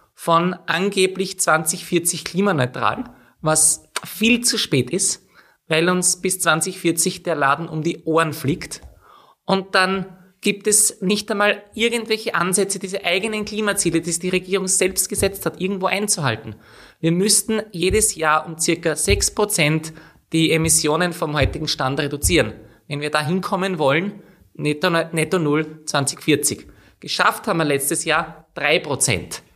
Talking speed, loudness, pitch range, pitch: 135 wpm, -19 LUFS, 155-195 Hz, 170 Hz